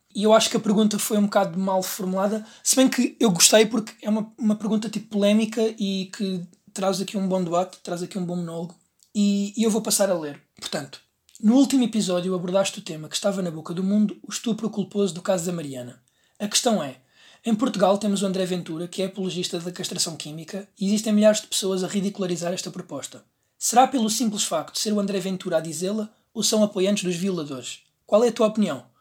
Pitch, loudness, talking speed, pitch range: 200 Hz, -23 LUFS, 220 wpm, 180-215 Hz